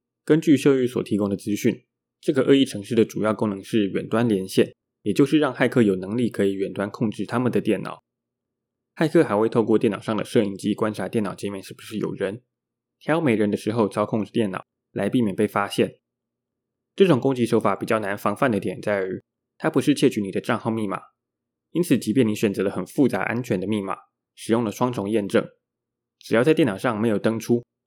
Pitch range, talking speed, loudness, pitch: 105-120 Hz, 310 characters per minute, -23 LUFS, 115 Hz